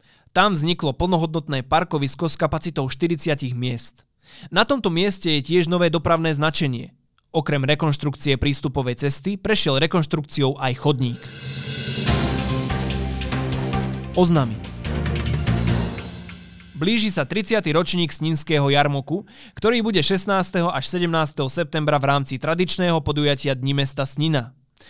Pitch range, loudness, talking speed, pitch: 130-170 Hz, -21 LUFS, 105 wpm, 150 Hz